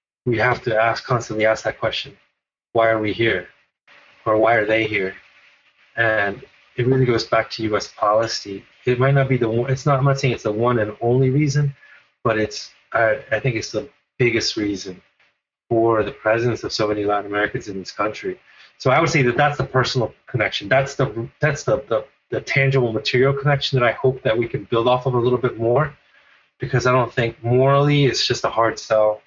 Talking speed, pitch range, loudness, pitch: 210 wpm, 110-135 Hz, -20 LUFS, 120 Hz